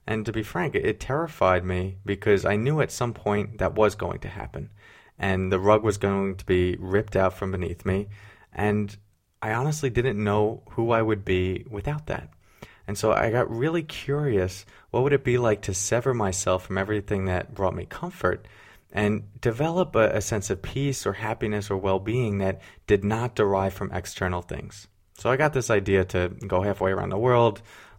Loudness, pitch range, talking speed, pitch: -25 LUFS, 95-115 Hz, 195 wpm, 105 Hz